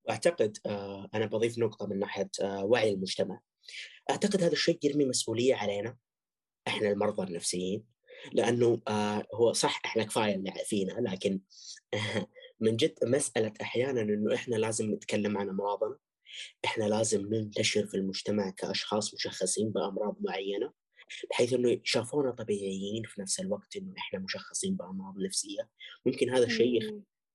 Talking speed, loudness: 125 wpm, -31 LUFS